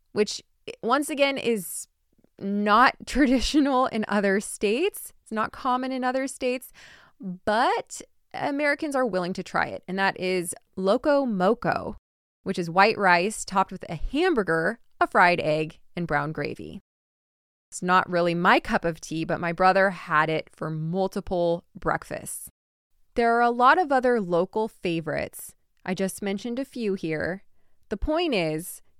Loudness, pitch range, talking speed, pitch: -25 LUFS, 175-250 Hz, 150 wpm, 195 Hz